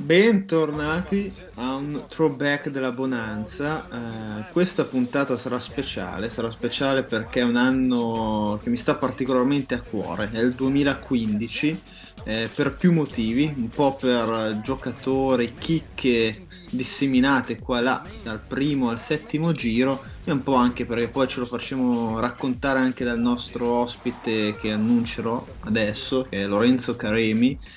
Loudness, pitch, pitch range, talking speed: -24 LUFS, 125 Hz, 115-140 Hz, 140 wpm